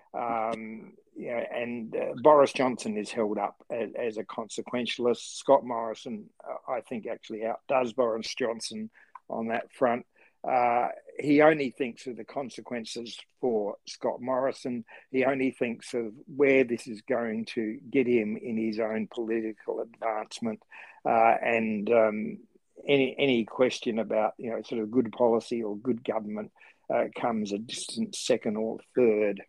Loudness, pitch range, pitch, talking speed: -29 LUFS, 110-130 Hz, 115 Hz, 150 wpm